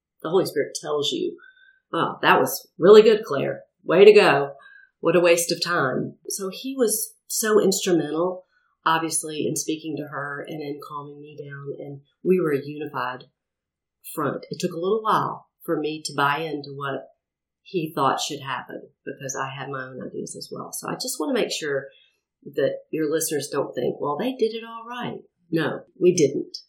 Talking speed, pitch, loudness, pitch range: 190 wpm, 170 Hz, -23 LUFS, 145-240 Hz